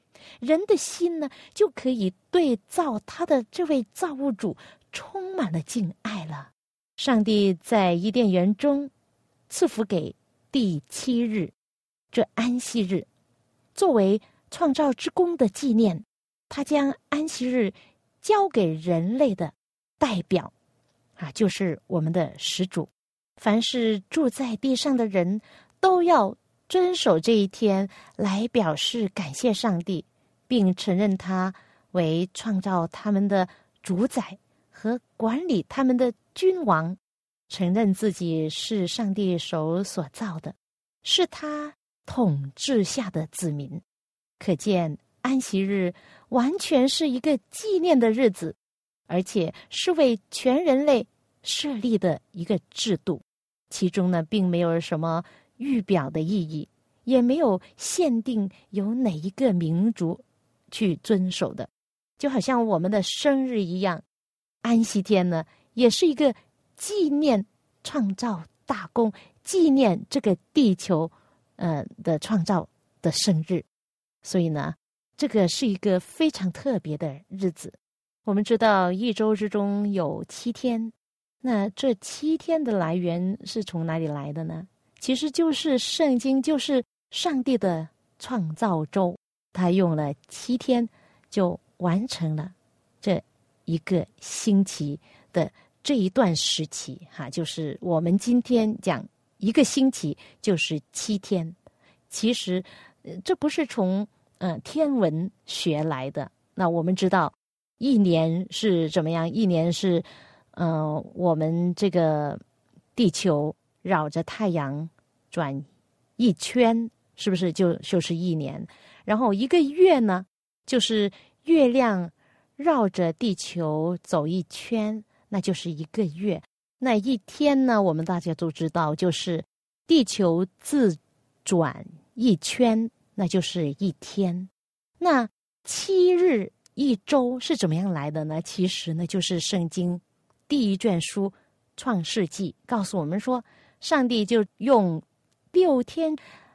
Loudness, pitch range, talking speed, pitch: -25 LUFS, 175-250 Hz, 185 characters per minute, 200 Hz